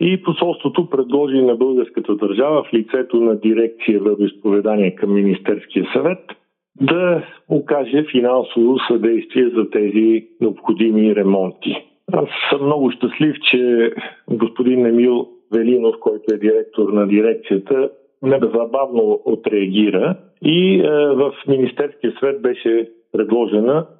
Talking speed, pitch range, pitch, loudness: 110 wpm, 110-145 Hz, 120 Hz, -17 LUFS